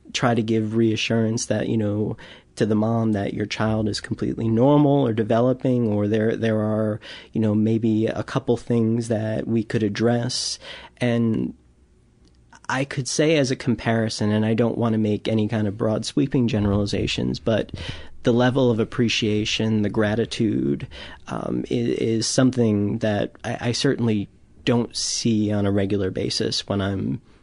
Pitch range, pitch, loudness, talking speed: 105-120 Hz, 110 Hz, -22 LUFS, 160 wpm